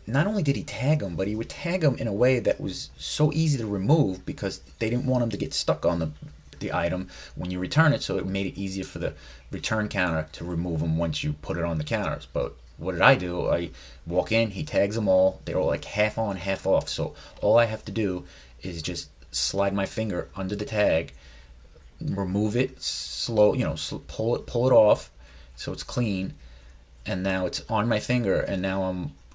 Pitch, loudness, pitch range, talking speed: 95 Hz, -26 LUFS, 80-110 Hz, 225 wpm